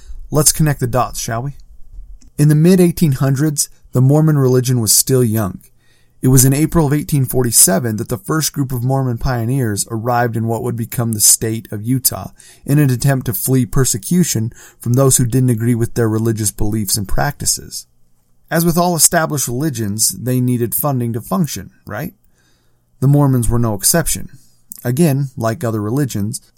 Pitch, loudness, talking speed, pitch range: 125 Hz, -15 LUFS, 170 wpm, 110-140 Hz